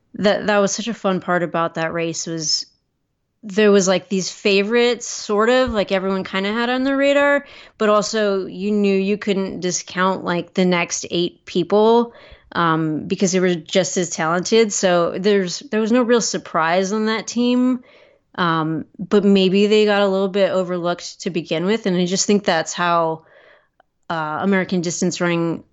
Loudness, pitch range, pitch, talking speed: -19 LUFS, 175-215 Hz, 195 Hz, 180 wpm